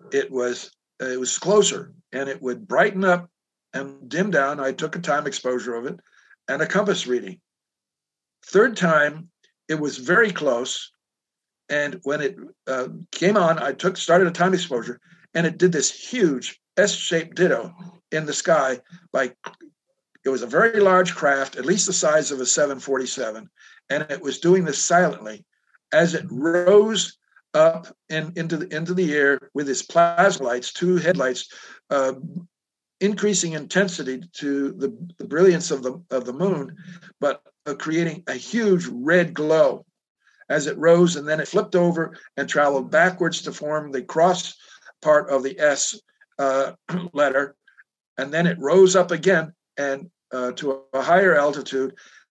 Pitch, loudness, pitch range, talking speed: 165 Hz, -21 LUFS, 140-180 Hz, 165 wpm